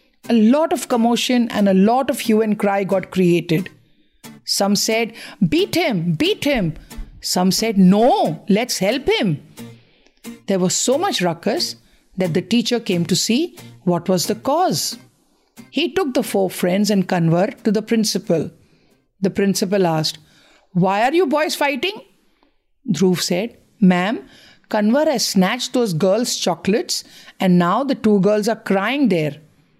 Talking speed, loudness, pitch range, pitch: 150 wpm, -18 LUFS, 185-245 Hz, 205 Hz